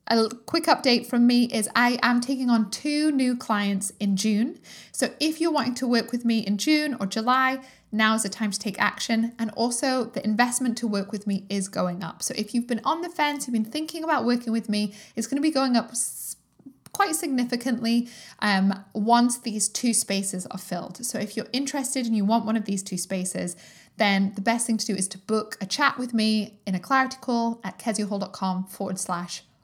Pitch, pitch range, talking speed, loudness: 230 Hz, 205-250 Hz, 215 wpm, -25 LUFS